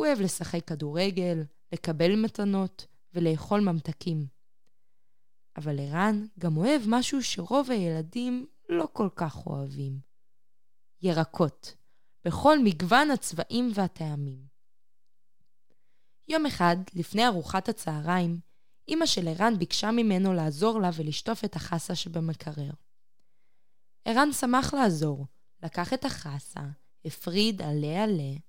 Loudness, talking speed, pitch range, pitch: -28 LUFS, 105 wpm, 155-220 Hz, 175 Hz